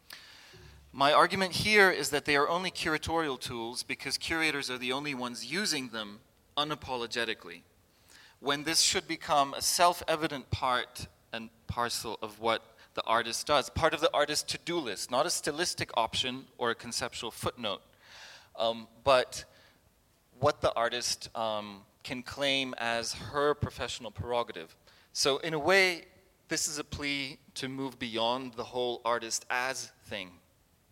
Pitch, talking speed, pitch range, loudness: 125 Hz, 150 wpm, 115-150 Hz, -30 LUFS